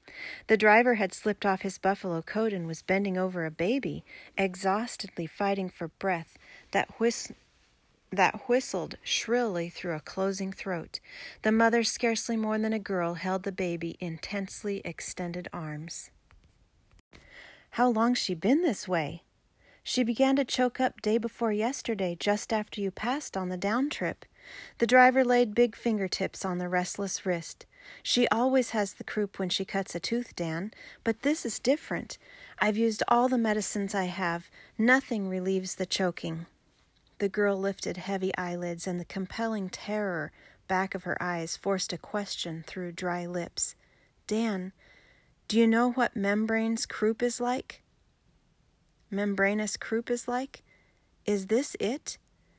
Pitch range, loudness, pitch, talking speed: 185-230 Hz, -29 LUFS, 200 Hz, 150 wpm